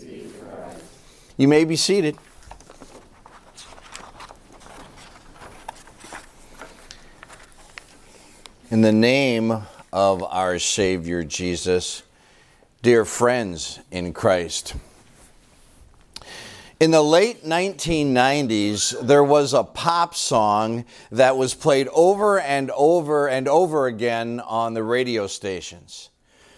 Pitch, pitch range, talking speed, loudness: 120 Hz, 100-145 Hz, 85 wpm, -20 LUFS